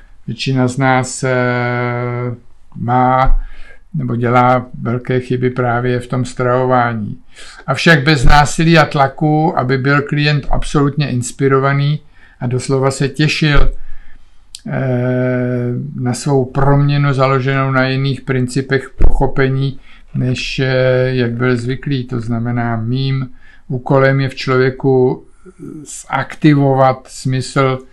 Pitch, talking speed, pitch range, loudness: 130 Hz, 100 wpm, 125-140 Hz, -15 LUFS